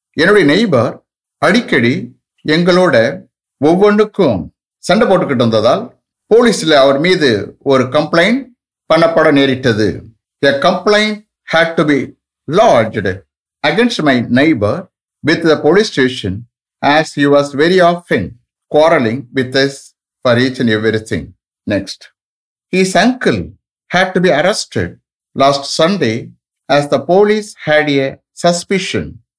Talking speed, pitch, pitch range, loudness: 75 wpm, 150 Hz, 125-180 Hz, -12 LUFS